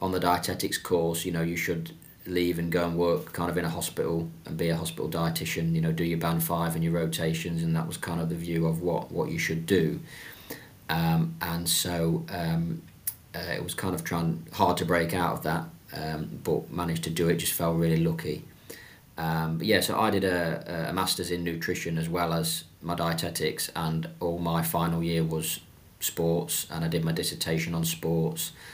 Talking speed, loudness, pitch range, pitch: 210 wpm, -28 LUFS, 80-85 Hz, 85 Hz